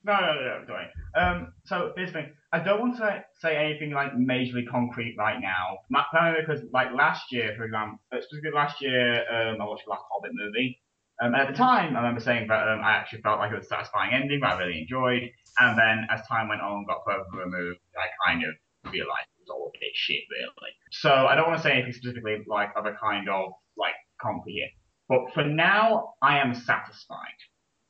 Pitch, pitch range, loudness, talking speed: 120 Hz, 105-150 Hz, -26 LUFS, 220 wpm